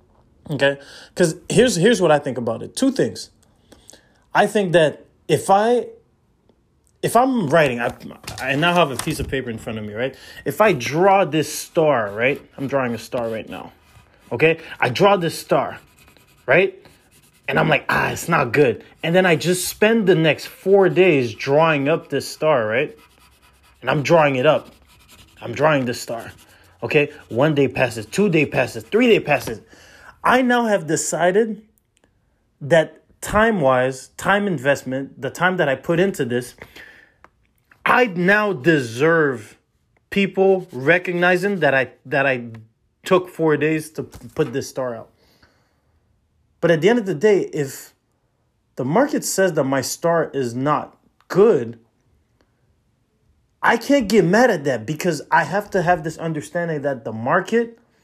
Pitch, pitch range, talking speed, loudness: 155 Hz, 130-190 Hz, 160 wpm, -19 LUFS